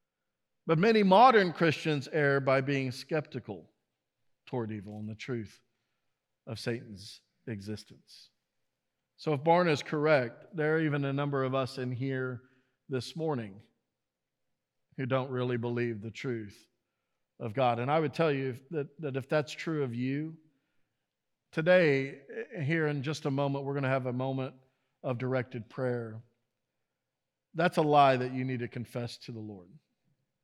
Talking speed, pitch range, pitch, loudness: 155 wpm, 120-150 Hz, 130 Hz, -30 LUFS